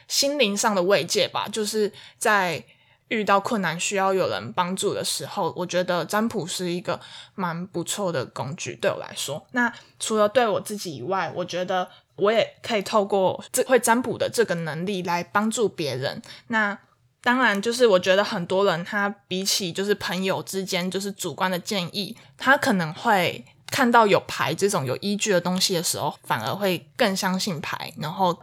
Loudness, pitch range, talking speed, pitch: -24 LUFS, 180-215 Hz, 270 characters per minute, 195 Hz